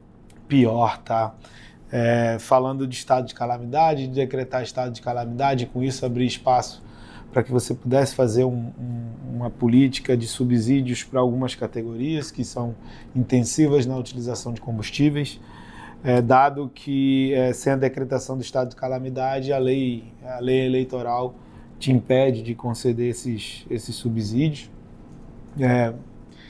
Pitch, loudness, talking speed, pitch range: 125 Hz, -23 LUFS, 140 wpm, 120-130 Hz